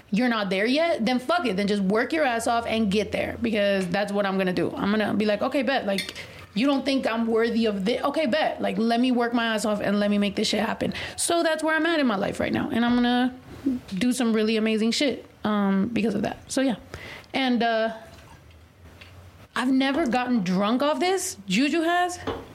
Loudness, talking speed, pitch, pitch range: -24 LUFS, 230 wpm, 230 Hz, 205-270 Hz